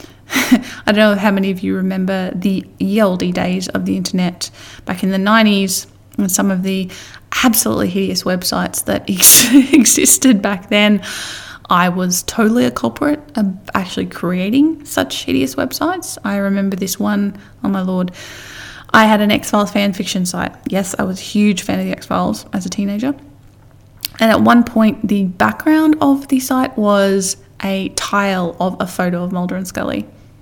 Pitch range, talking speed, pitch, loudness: 185-225 Hz, 170 wpm, 200 Hz, -15 LUFS